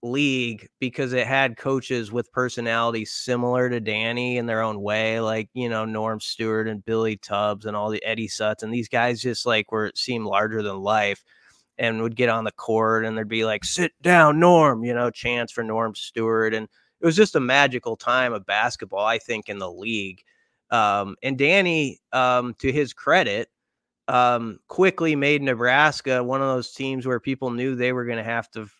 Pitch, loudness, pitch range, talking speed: 120 Hz, -22 LUFS, 110-130 Hz, 195 wpm